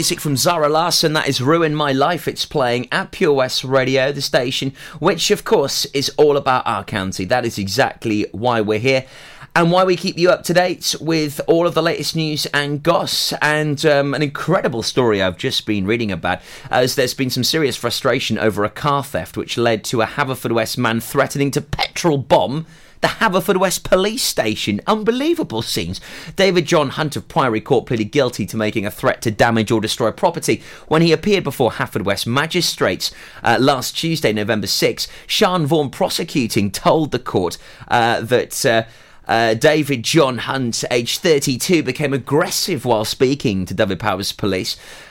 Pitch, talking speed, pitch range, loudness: 140 Hz, 180 wpm, 115-160 Hz, -17 LUFS